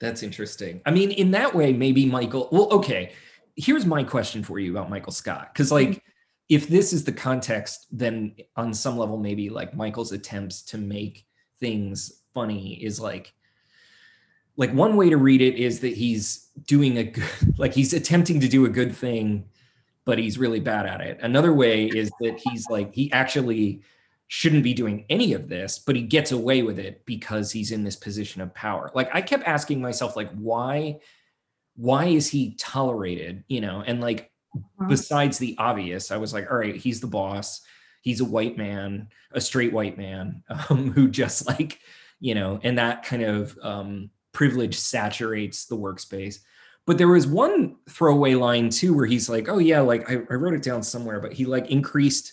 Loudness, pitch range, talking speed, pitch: -23 LUFS, 105-140 Hz, 190 wpm, 120 Hz